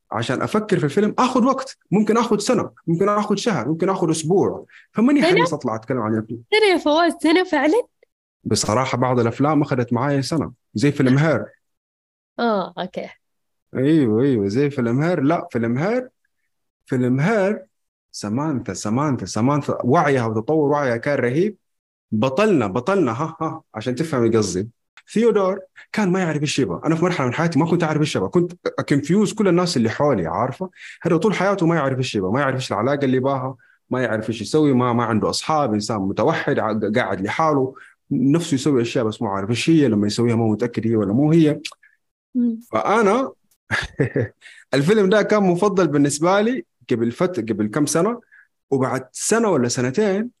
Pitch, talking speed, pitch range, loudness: 150 Hz, 165 wpm, 125-195 Hz, -20 LUFS